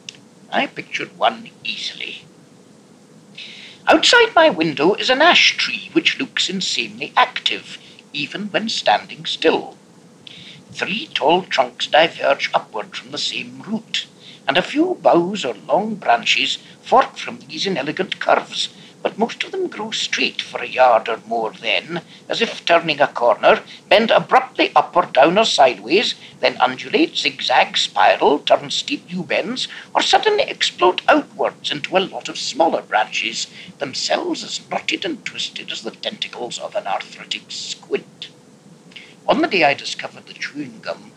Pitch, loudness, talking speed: 225 Hz, -18 LUFS, 150 wpm